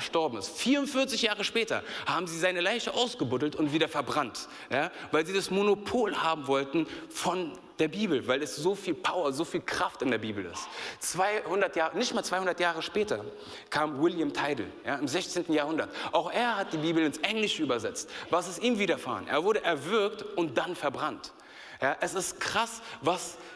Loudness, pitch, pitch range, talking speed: -30 LUFS, 180 Hz, 160-215 Hz, 185 wpm